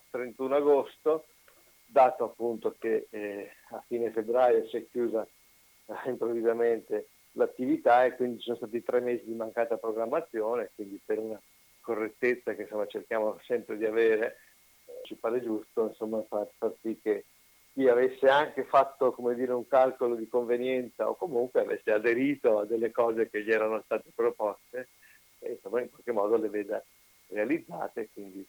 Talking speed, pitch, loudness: 160 wpm, 125 Hz, -29 LUFS